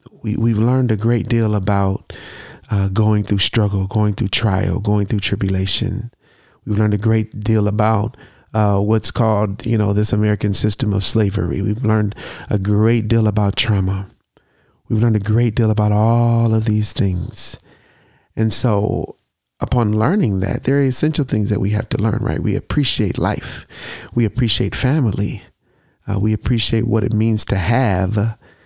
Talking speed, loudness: 165 wpm, -17 LUFS